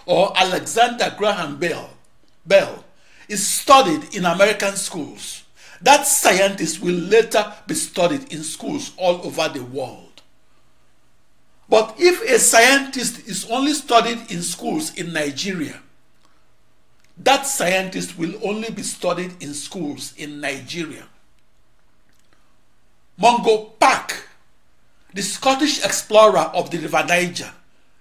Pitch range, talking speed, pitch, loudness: 175-240 Hz, 110 wpm, 200 Hz, -18 LUFS